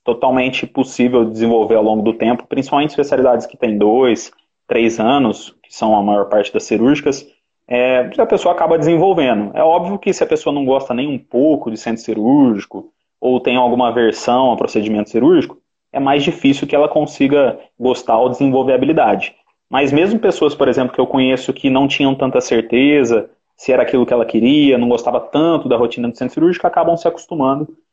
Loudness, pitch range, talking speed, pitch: -14 LUFS, 120-145 Hz, 195 wpm, 130 Hz